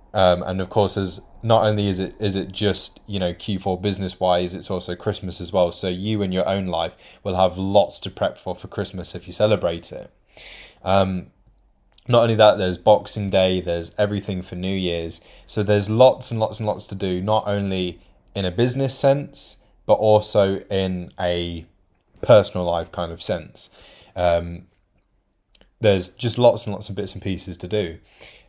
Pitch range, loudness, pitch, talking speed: 90-105 Hz, -21 LUFS, 95 Hz, 185 wpm